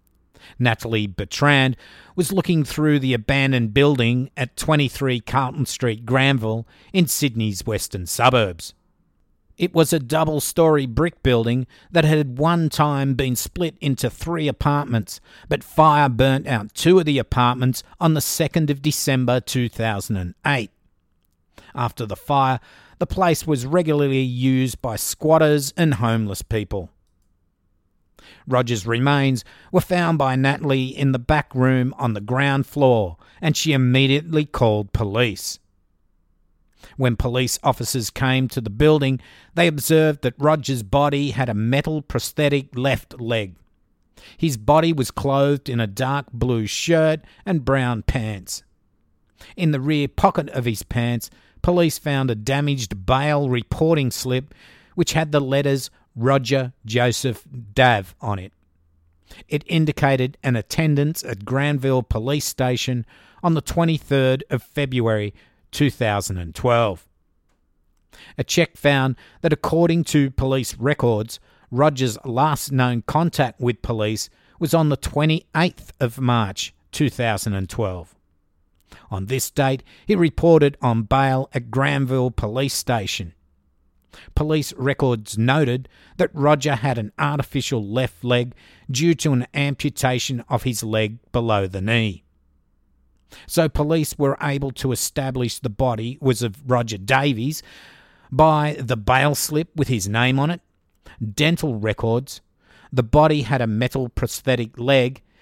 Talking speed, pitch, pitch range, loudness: 130 wpm, 130 Hz, 110-145 Hz, -20 LUFS